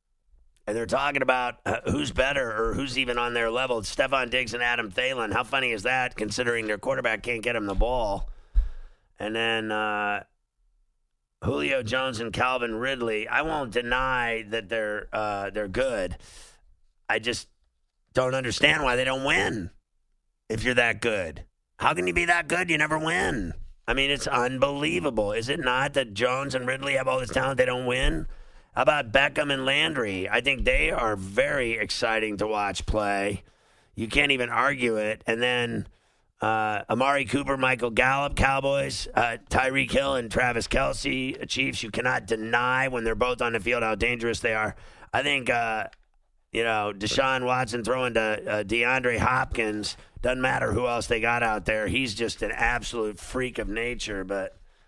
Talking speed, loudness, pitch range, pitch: 175 wpm, -26 LUFS, 110-130 Hz, 120 Hz